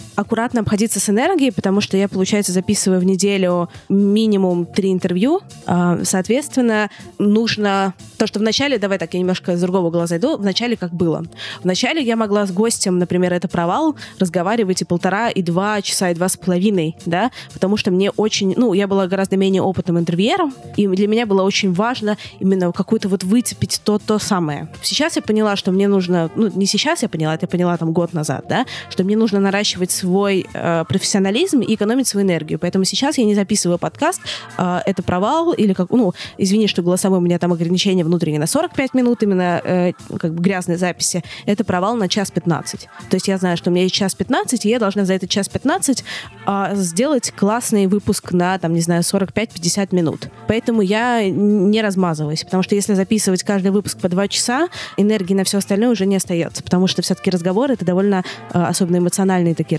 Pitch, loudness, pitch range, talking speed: 195 Hz, -17 LUFS, 180-210 Hz, 195 wpm